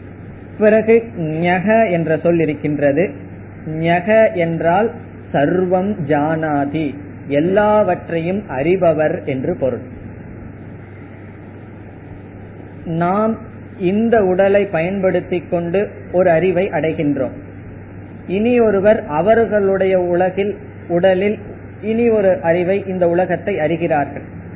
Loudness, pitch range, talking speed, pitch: -16 LUFS, 120-190 Hz, 80 wpm, 170 Hz